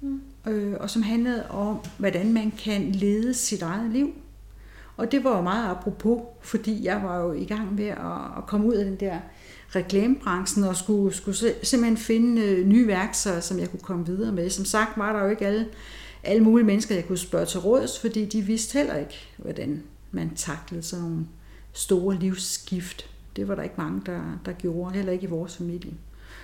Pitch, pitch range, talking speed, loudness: 200 Hz, 180-220 Hz, 190 wpm, -25 LUFS